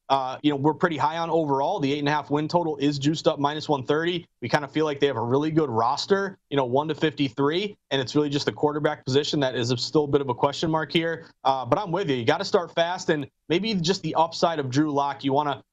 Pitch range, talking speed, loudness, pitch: 140-165 Hz, 280 wpm, -24 LUFS, 150 Hz